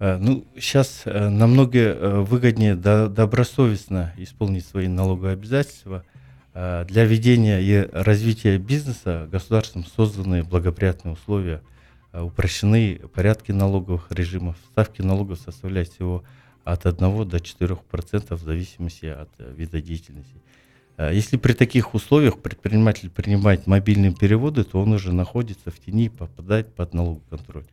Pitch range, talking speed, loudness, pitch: 90-110 Hz, 115 wpm, -21 LUFS, 100 Hz